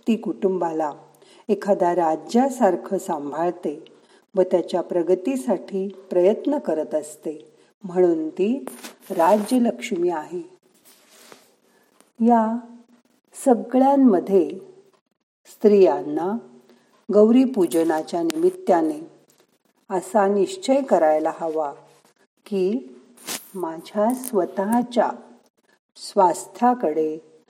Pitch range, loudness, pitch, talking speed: 170-240 Hz, -21 LUFS, 195 Hz, 60 wpm